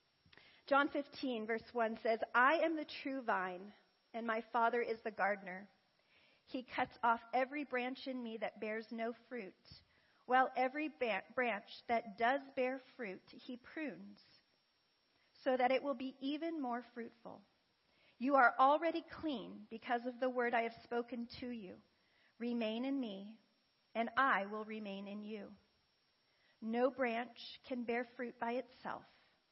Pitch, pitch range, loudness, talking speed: 240 Hz, 225-260 Hz, -39 LUFS, 150 wpm